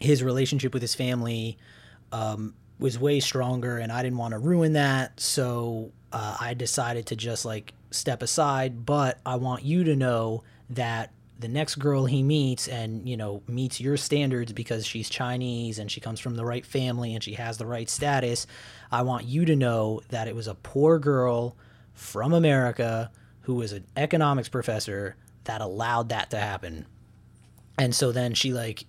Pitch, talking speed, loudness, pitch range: 120 Hz, 180 wpm, -27 LUFS, 115-130 Hz